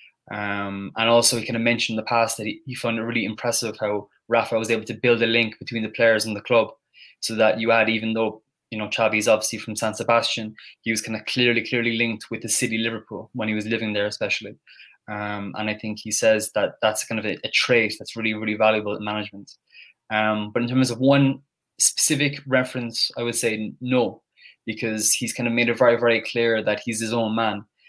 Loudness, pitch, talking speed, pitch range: -22 LUFS, 115 Hz, 230 wpm, 110-120 Hz